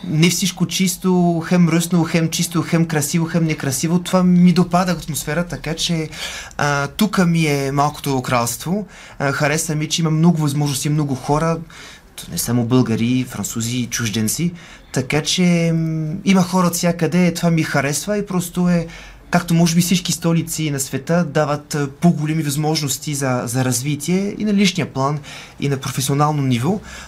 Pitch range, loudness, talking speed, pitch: 140-175 Hz, -18 LUFS, 155 wpm, 160 Hz